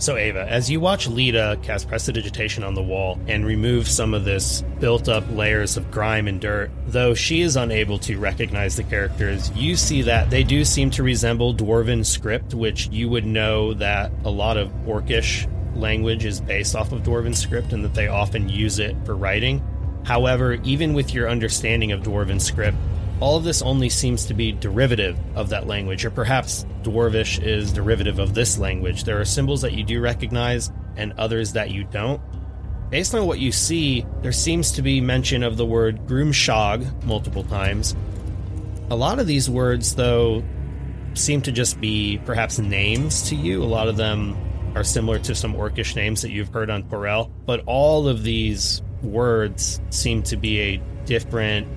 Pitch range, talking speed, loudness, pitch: 100-120 Hz, 185 wpm, -21 LUFS, 110 Hz